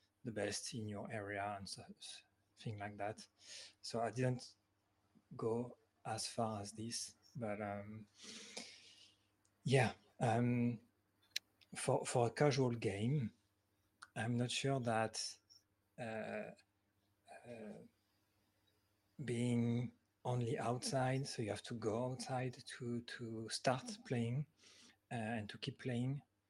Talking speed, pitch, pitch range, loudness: 115 wpm, 110 Hz, 105-120 Hz, -42 LUFS